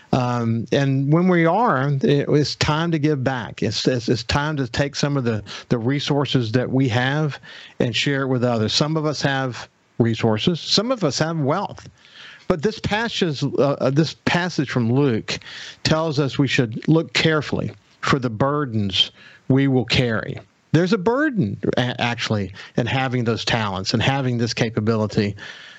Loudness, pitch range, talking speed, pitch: -20 LUFS, 120-155 Hz, 170 wpm, 135 Hz